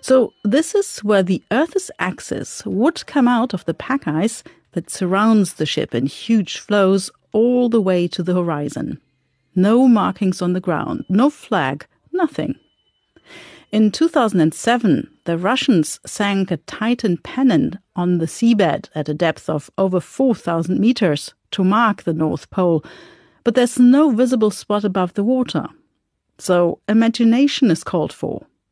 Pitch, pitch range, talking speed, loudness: 210 Hz, 180-250 Hz, 150 wpm, -18 LUFS